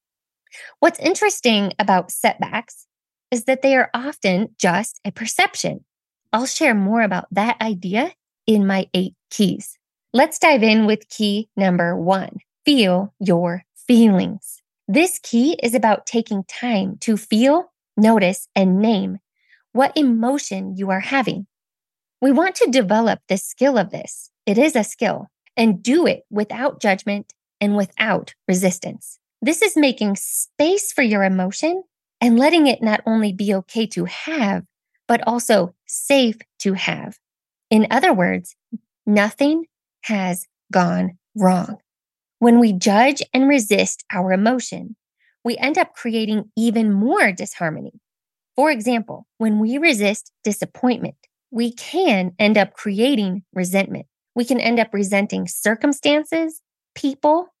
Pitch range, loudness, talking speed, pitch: 200-265 Hz, -19 LUFS, 135 wpm, 225 Hz